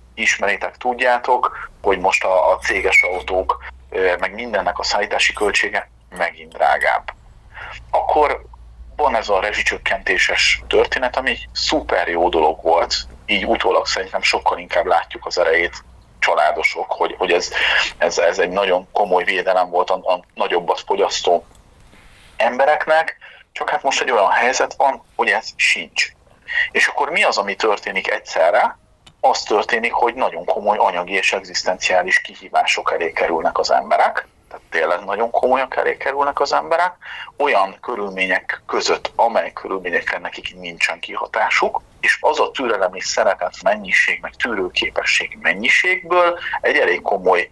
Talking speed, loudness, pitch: 140 wpm, -18 LUFS, 180 Hz